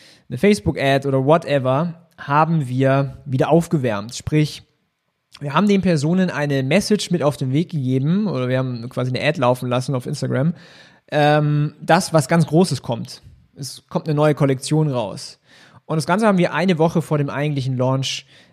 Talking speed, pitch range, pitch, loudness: 170 wpm, 130-165 Hz, 150 Hz, -19 LUFS